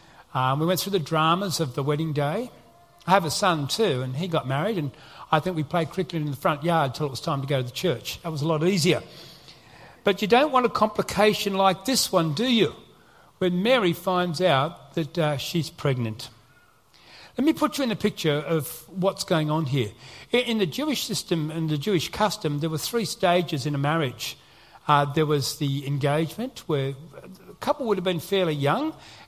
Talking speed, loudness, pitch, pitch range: 210 wpm, -25 LUFS, 165 Hz, 145-190 Hz